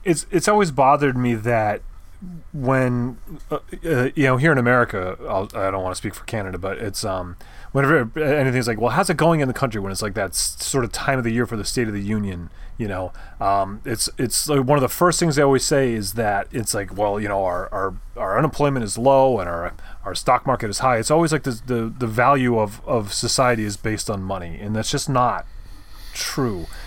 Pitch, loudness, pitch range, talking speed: 120 Hz, -21 LUFS, 105-135 Hz, 230 wpm